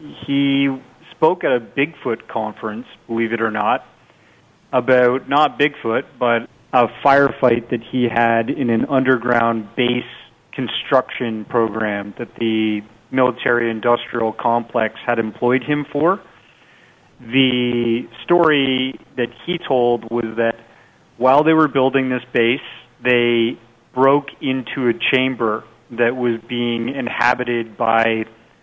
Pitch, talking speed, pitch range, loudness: 120 Hz, 120 wpm, 115-130 Hz, -18 LUFS